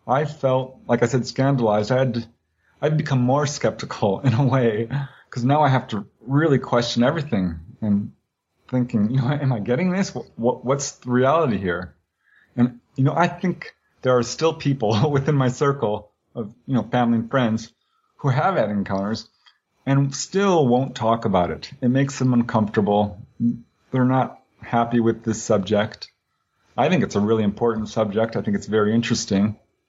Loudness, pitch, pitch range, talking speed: -21 LUFS, 125 Hz, 110-135 Hz, 175 wpm